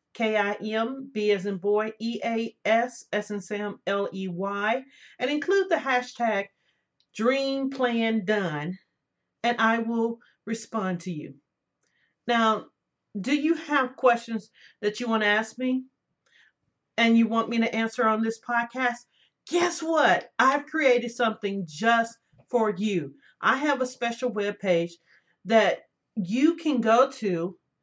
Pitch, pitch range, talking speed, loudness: 225 Hz, 205-250 Hz, 145 wpm, -26 LUFS